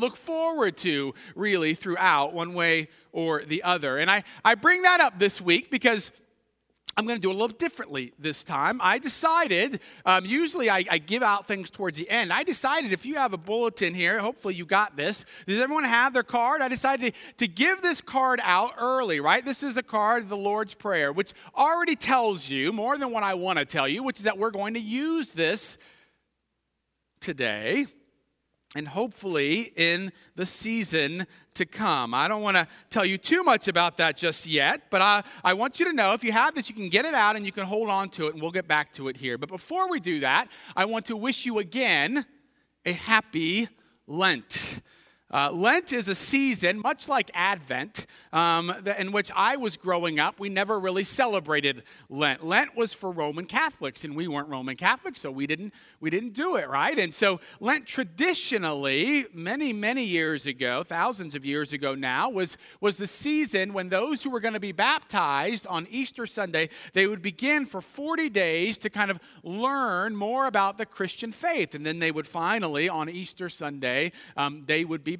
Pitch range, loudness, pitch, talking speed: 170-245 Hz, -25 LUFS, 200 Hz, 200 wpm